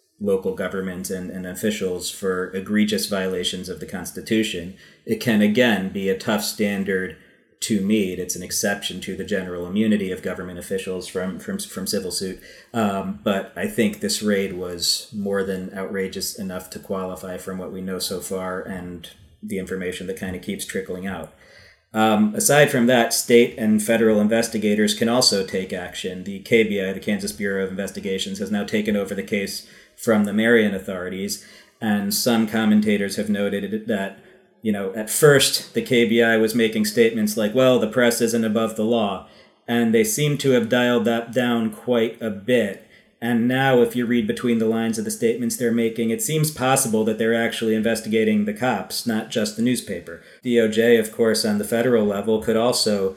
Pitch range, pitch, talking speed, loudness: 95-120 Hz, 110 Hz, 185 wpm, -21 LUFS